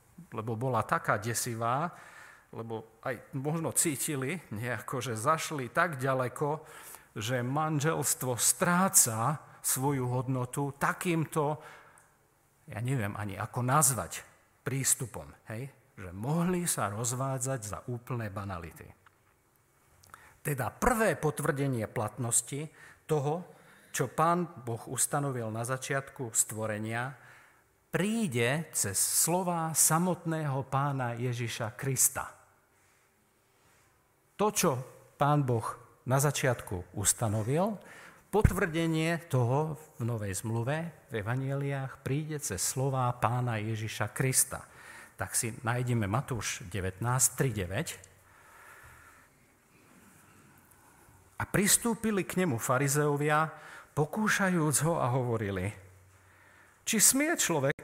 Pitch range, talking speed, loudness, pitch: 115-155 Hz, 95 wpm, -30 LUFS, 135 Hz